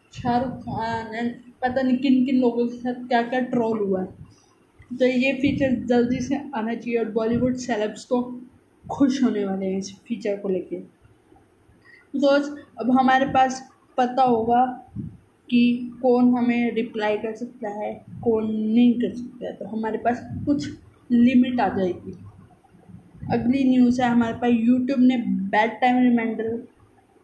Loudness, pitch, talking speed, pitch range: -22 LUFS, 245 Hz, 150 wpm, 225-255 Hz